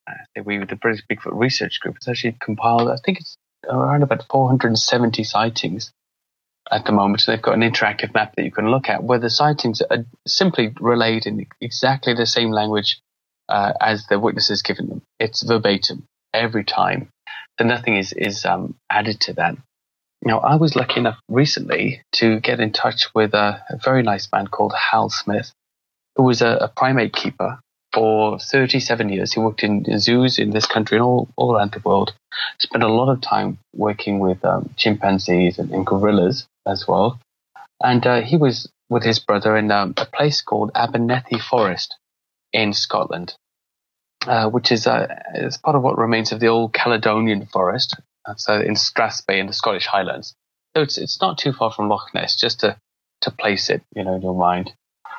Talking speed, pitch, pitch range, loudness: 185 wpm, 115 Hz, 105-125 Hz, -19 LUFS